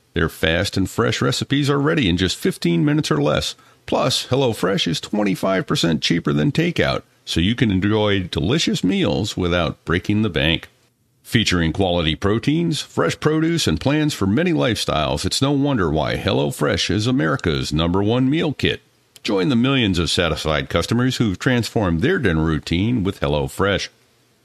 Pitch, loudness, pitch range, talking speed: 105 Hz, -19 LUFS, 85-140 Hz, 155 wpm